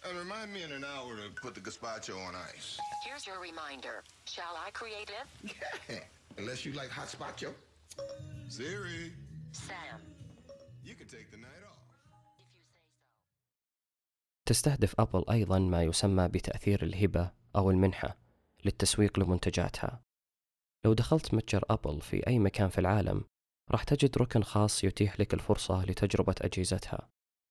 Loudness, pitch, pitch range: -33 LUFS, 105 Hz, 95-135 Hz